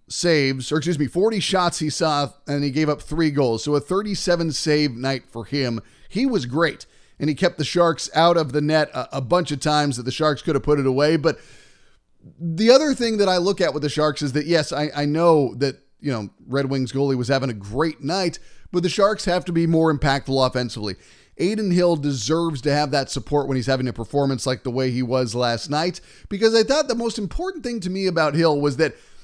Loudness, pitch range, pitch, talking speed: -21 LUFS, 135-175 Hz, 150 Hz, 235 wpm